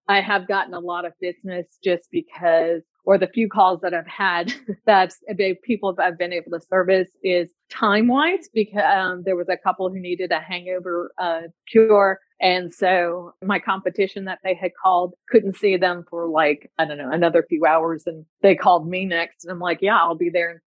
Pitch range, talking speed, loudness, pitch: 170-195 Hz, 205 wpm, -21 LUFS, 180 Hz